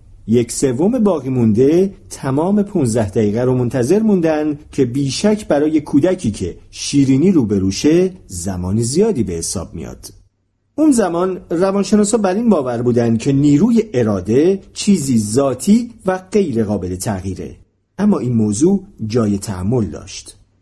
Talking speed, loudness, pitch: 130 wpm, -16 LUFS, 125 Hz